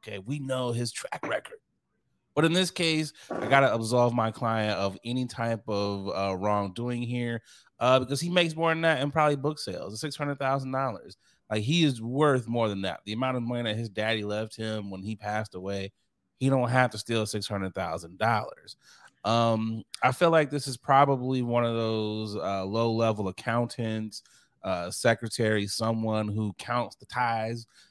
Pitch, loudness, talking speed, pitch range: 115 Hz, -28 LUFS, 175 wpm, 105-135 Hz